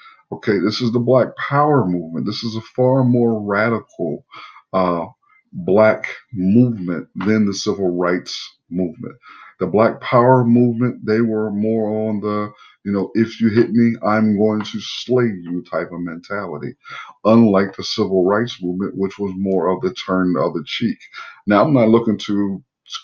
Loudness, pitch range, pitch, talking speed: -18 LUFS, 95-115 Hz, 105 Hz, 165 wpm